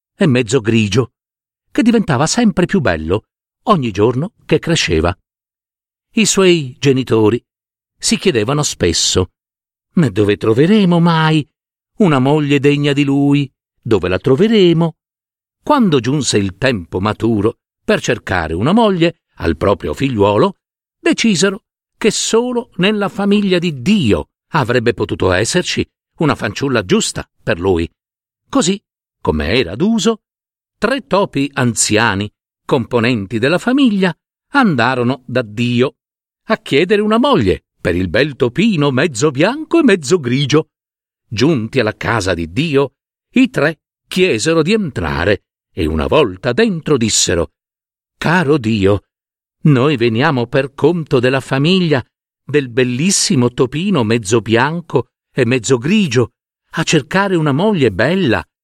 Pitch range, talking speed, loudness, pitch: 115-180 Hz, 120 wpm, -14 LUFS, 140 Hz